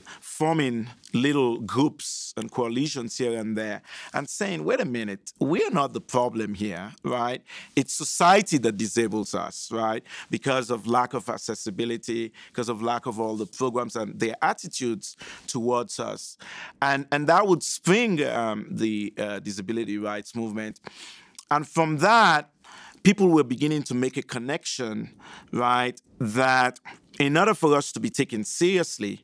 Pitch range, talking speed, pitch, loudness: 110-145 Hz, 150 wpm, 125 Hz, -25 LUFS